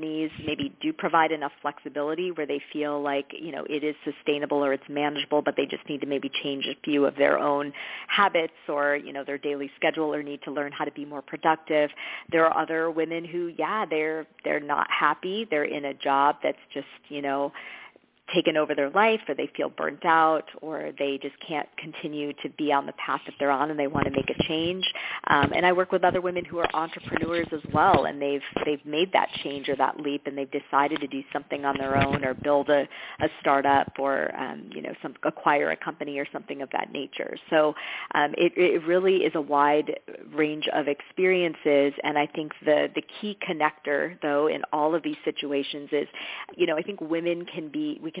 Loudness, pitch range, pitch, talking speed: -26 LUFS, 145-160 Hz, 150 Hz, 215 wpm